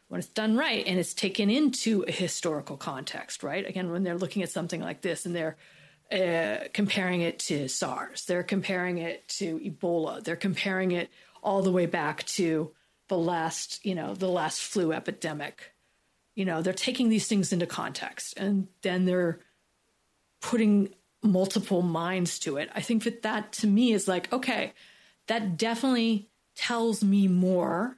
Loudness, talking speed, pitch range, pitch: -29 LUFS, 165 wpm, 175-210 Hz, 185 Hz